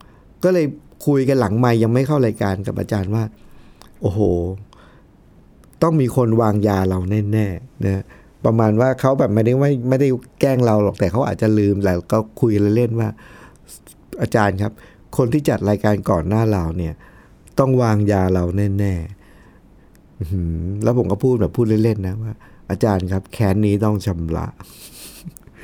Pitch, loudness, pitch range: 105 Hz, -19 LUFS, 100-120 Hz